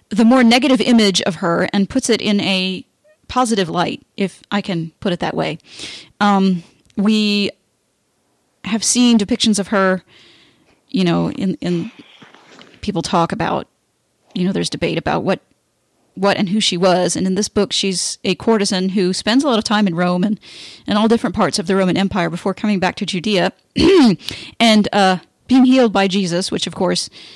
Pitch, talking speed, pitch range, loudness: 200 Hz, 180 wpm, 185-215 Hz, -16 LUFS